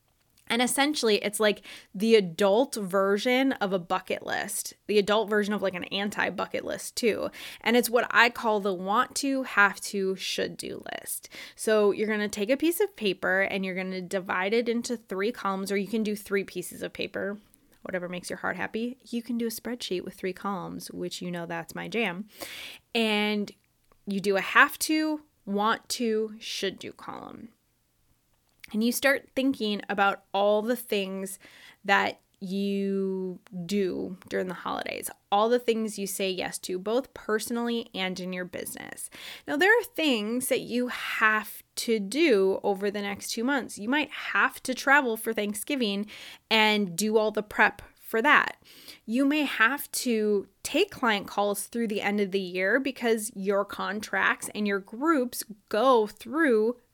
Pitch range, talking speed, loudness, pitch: 200-240 Hz, 175 wpm, -27 LUFS, 215 Hz